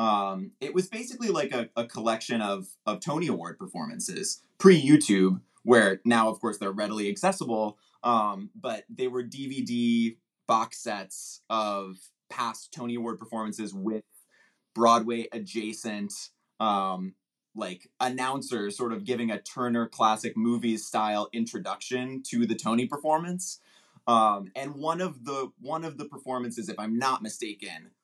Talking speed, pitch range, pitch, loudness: 140 wpm, 110-130 Hz, 115 Hz, -28 LUFS